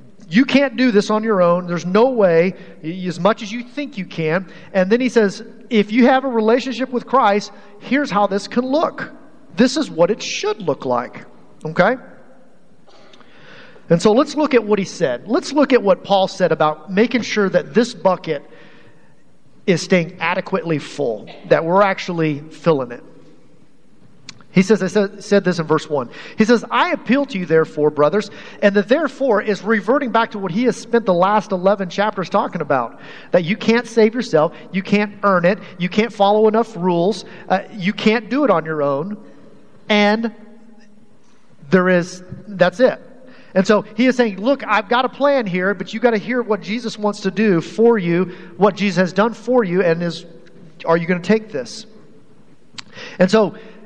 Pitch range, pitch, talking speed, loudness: 180-230 Hz, 205 Hz, 190 wpm, -17 LUFS